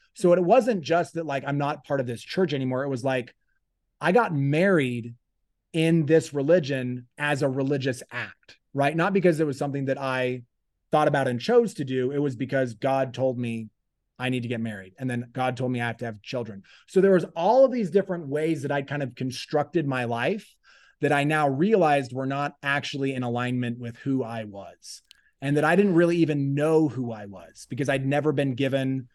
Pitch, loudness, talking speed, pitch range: 140 Hz, -25 LUFS, 215 wpm, 125-155 Hz